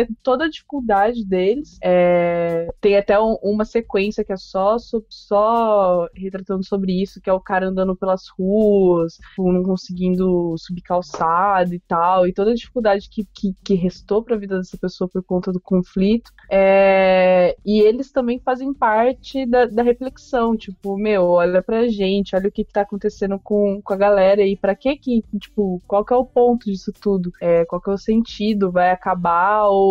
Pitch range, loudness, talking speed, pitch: 185-220 Hz, -18 LUFS, 180 wpm, 200 Hz